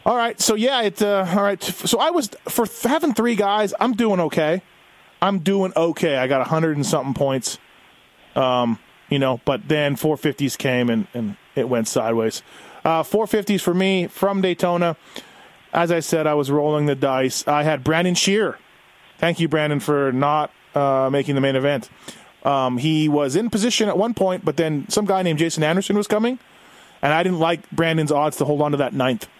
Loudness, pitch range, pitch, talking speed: -20 LUFS, 140-195 Hz, 160 Hz, 205 wpm